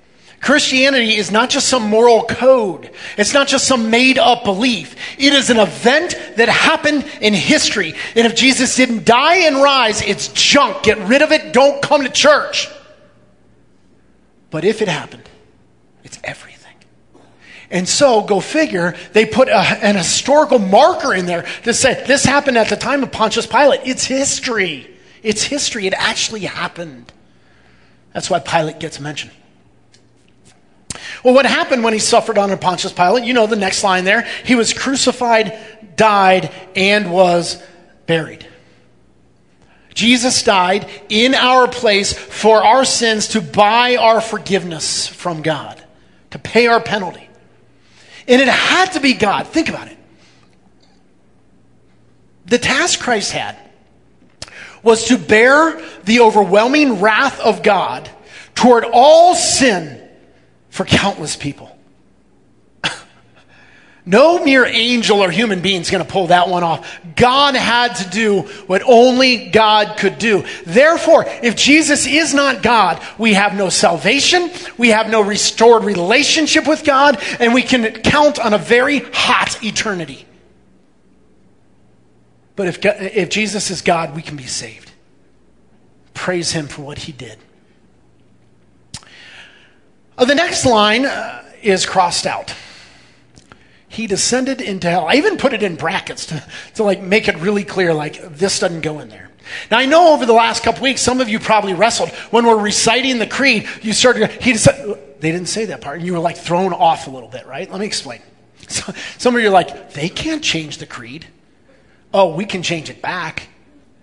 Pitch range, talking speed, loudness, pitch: 185-255 Hz, 155 wpm, -13 LUFS, 220 Hz